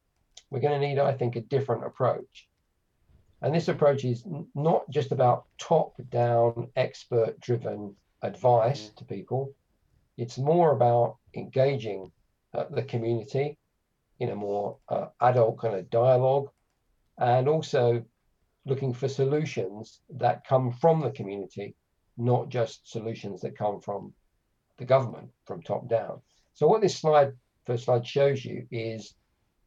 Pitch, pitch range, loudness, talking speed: 125 Hz, 115-140 Hz, -27 LUFS, 140 wpm